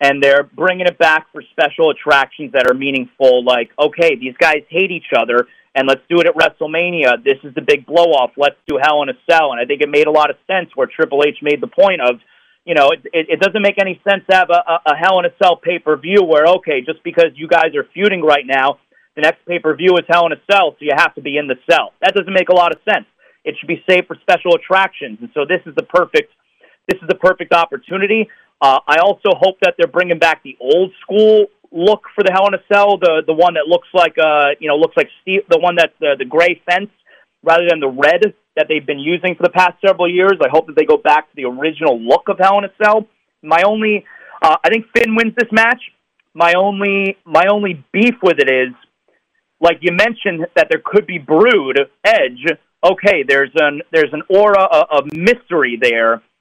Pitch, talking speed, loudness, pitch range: 175 Hz, 240 wpm, -13 LUFS, 150-195 Hz